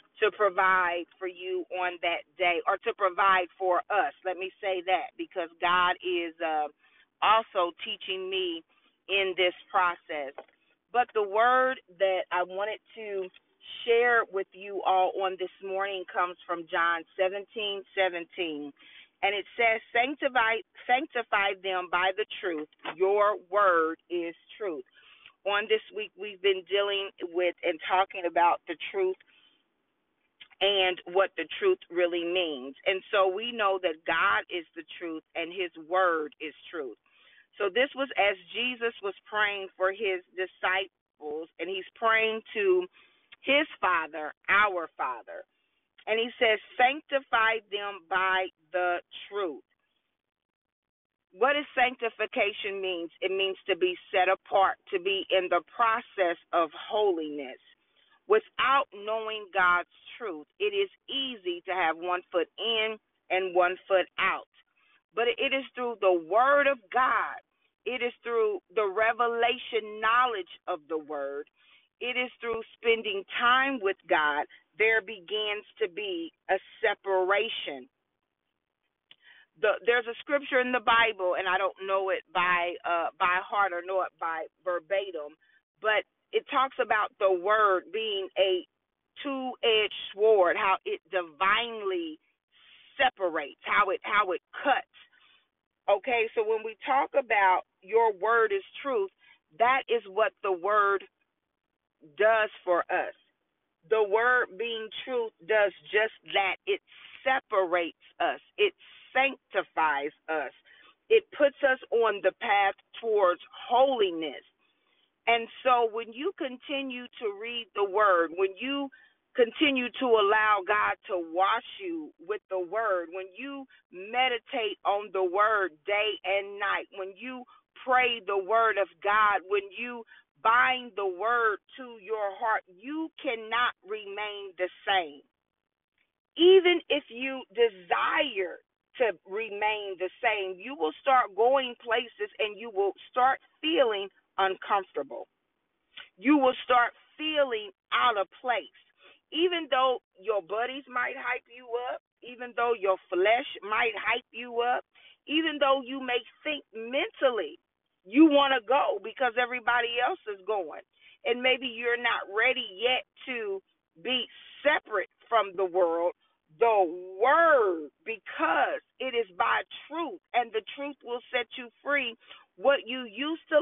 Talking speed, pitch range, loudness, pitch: 135 wpm, 190-275 Hz, -28 LUFS, 225 Hz